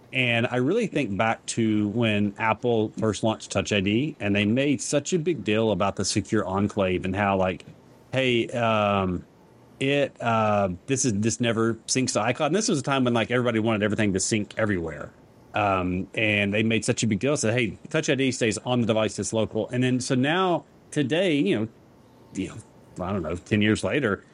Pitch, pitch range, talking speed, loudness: 110 Hz, 105-125 Hz, 205 wpm, -24 LUFS